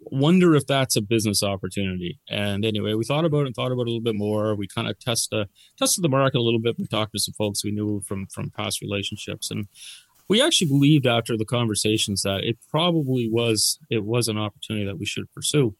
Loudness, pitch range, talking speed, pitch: -23 LUFS, 105-130 Hz, 230 wpm, 110 Hz